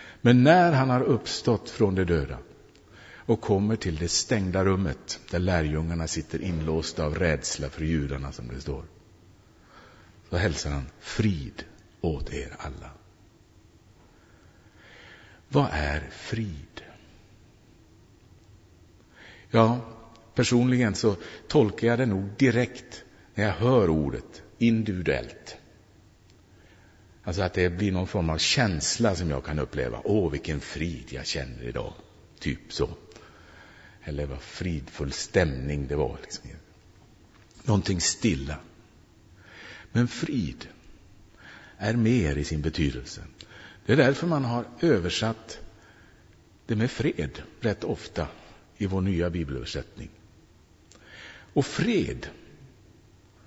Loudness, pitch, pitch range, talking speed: -27 LUFS, 95 Hz, 80-110 Hz, 115 wpm